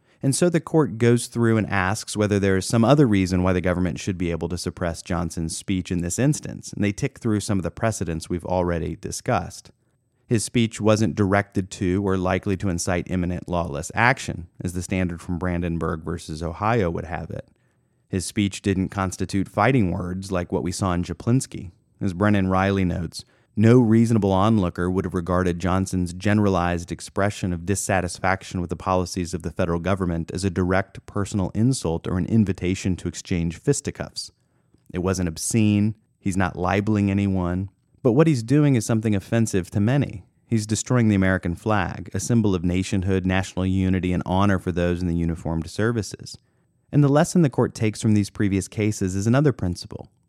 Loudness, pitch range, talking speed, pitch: -23 LUFS, 90-110 Hz, 185 wpm, 95 Hz